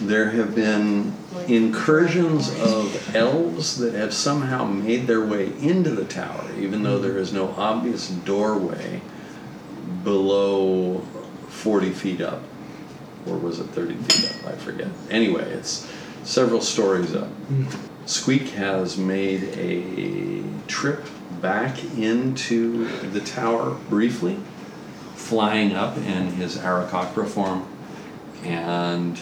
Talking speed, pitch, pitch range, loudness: 115 wpm, 105 Hz, 95-115 Hz, -23 LUFS